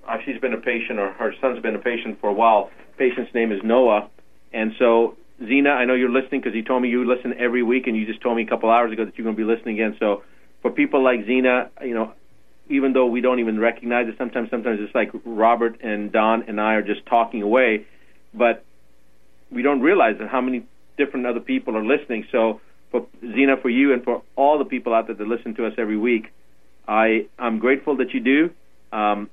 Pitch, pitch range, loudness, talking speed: 115 Hz, 110-125 Hz, -21 LUFS, 230 wpm